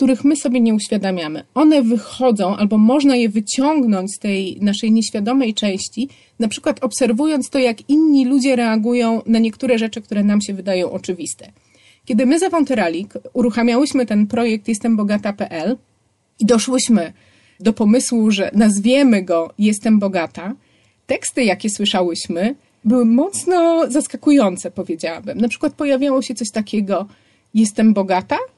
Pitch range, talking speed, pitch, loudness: 205-260 Hz, 135 wpm, 225 Hz, -17 LUFS